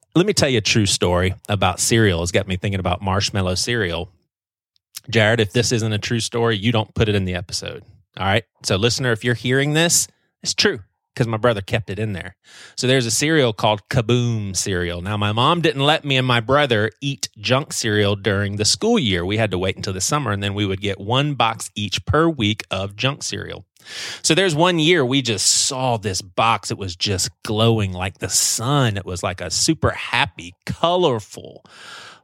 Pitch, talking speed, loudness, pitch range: 110 Hz, 210 wpm, -19 LUFS, 100-130 Hz